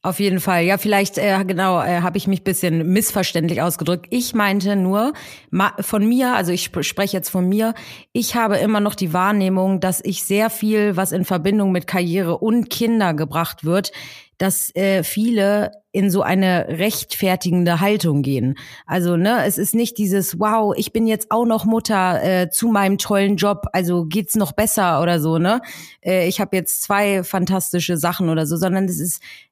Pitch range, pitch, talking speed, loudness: 180-205 Hz, 190 Hz, 190 wpm, -18 LUFS